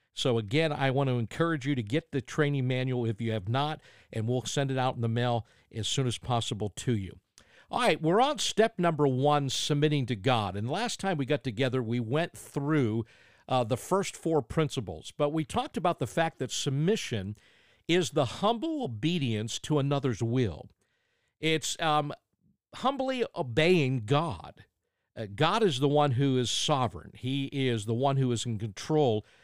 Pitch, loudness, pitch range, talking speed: 135 Hz, -29 LUFS, 120-155 Hz, 185 wpm